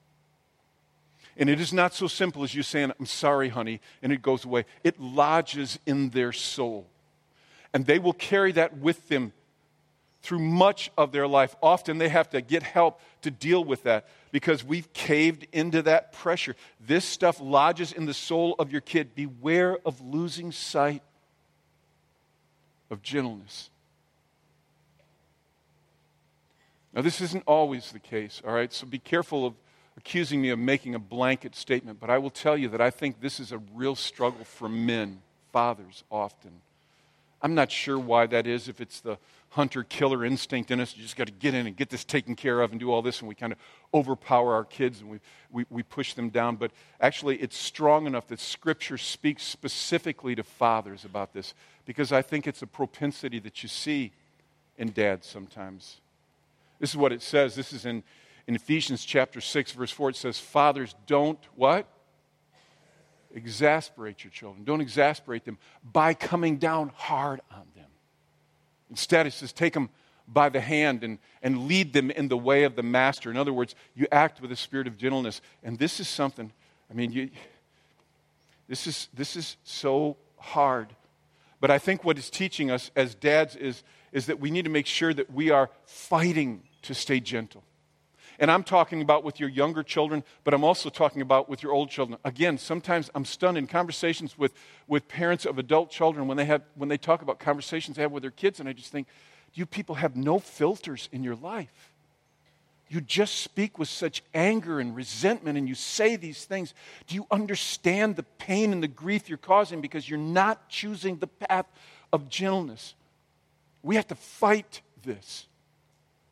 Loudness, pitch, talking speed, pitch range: -27 LUFS, 140 Hz, 185 wpm, 125-160 Hz